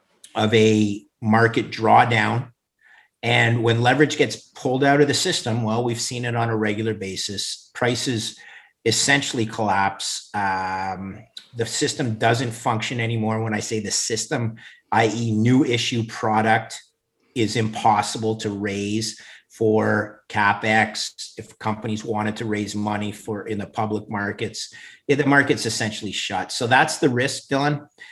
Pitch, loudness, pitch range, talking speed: 110 Hz, -21 LUFS, 105-120 Hz, 140 wpm